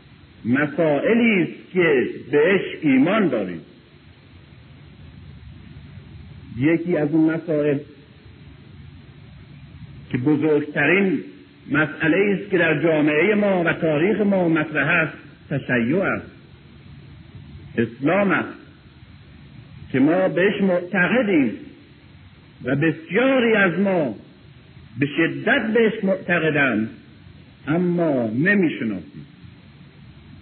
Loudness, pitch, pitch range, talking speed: -20 LUFS, 165 Hz, 150-195 Hz, 85 wpm